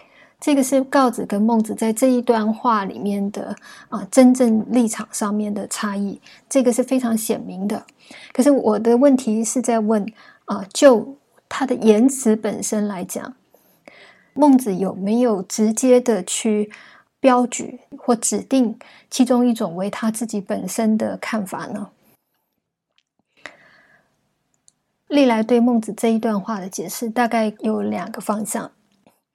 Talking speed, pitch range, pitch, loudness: 205 characters per minute, 215-255 Hz, 225 Hz, -19 LUFS